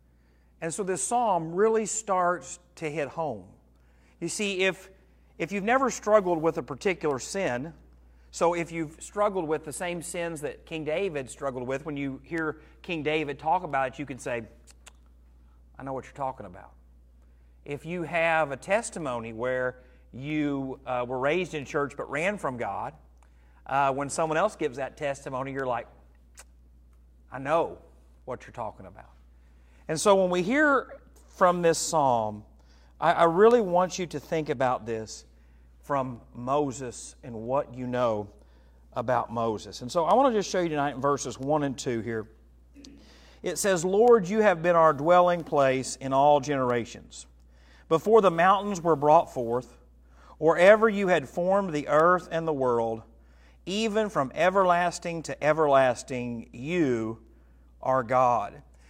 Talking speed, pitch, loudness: 160 wpm, 140 Hz, -26 LUFS